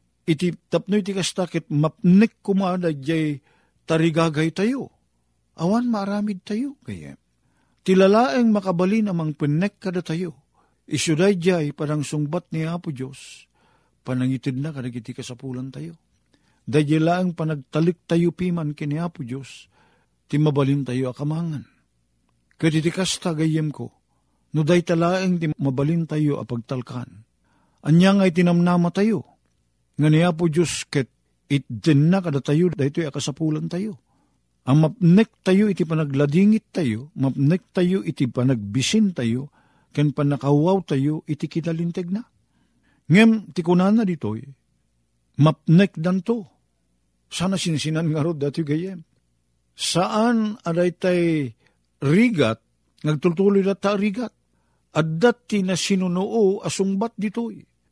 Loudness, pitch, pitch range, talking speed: -21 LUFS, 160 Hz, 140-185 Hz, 115 wpm